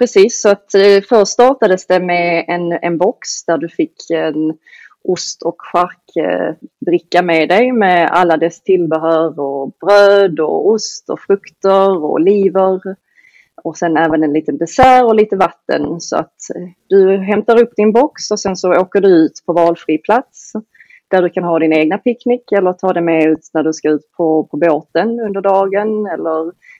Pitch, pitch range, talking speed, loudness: 185 Hz, 165-210 Hz, 170 wpm, -13 LUFS